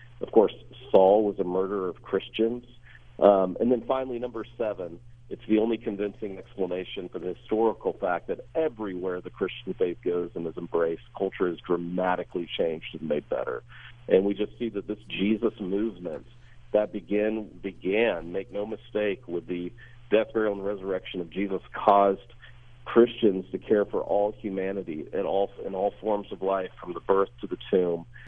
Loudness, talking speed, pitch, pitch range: -27 LUFS, 170 wpm, 105 Hz, 95-115 Hz